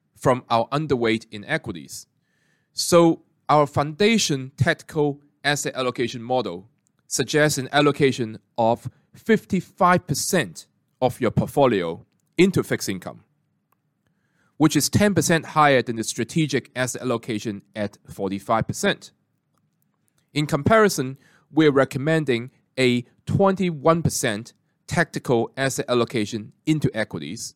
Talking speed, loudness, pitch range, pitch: 100 wpm, -22 LUFS, 120-160 Hz, 140 Hz